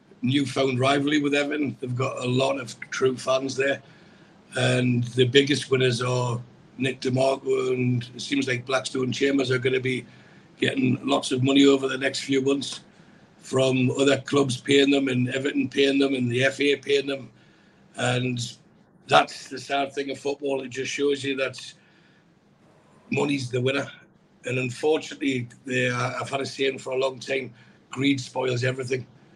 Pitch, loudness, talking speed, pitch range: 135 Hz, -24 LUFS, 165 wpm, 130-140 Hz